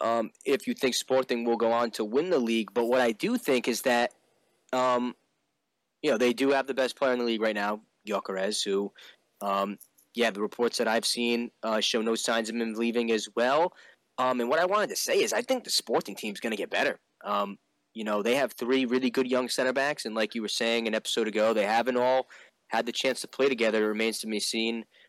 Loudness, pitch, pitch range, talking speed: -28 LUFS, 115 Hz, 110-125 Hz, 240 wpm